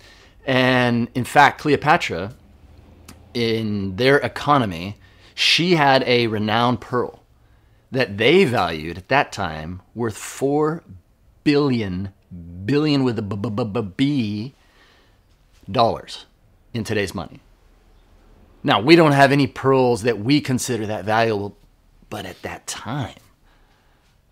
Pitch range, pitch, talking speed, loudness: 95-130 Hz, 110 Hz, 120 wpm, -19 LUFS